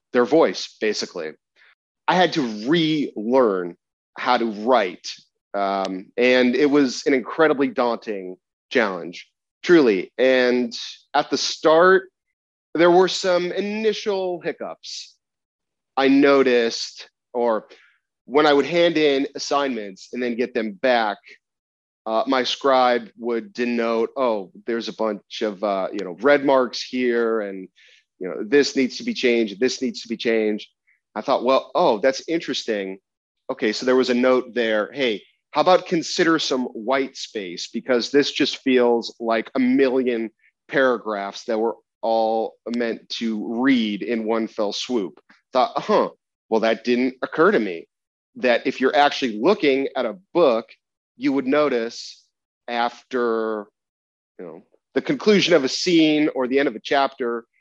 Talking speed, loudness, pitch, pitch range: 150 wpm, -21 LUFS, 125 Hz, 115-145 Hz